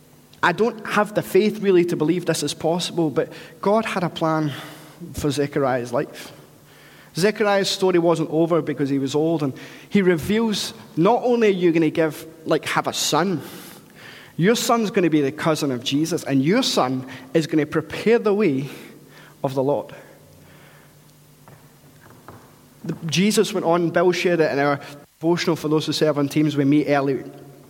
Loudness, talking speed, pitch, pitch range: -21 LUFS, 165 wpm, 160 Hz, 145-180 Hz